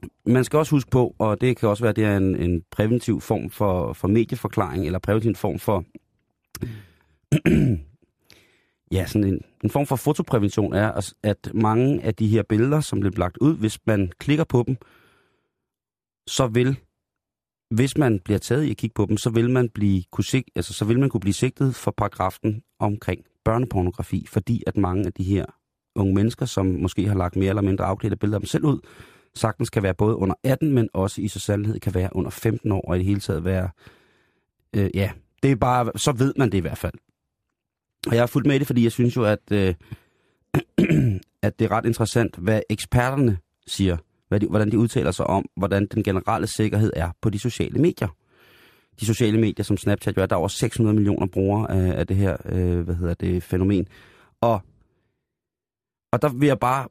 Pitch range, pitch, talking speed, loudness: 95-120 Hz, 105 Hz, 205 wpm, -23 LUFS